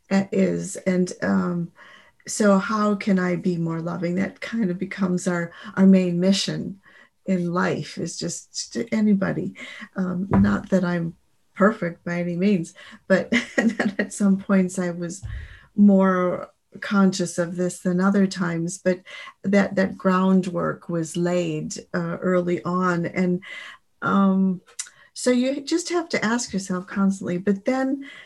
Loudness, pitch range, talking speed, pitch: -23 LUFS, 175-205 Hz, 140 wpm, 190 Hz